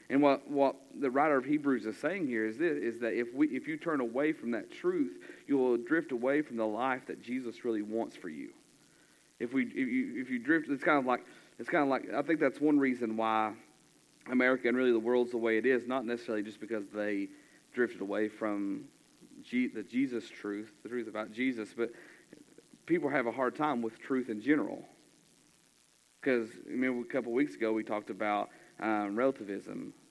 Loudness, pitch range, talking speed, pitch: -33 LUFS, 110-150 Hz, 210 wpm, 125 Hz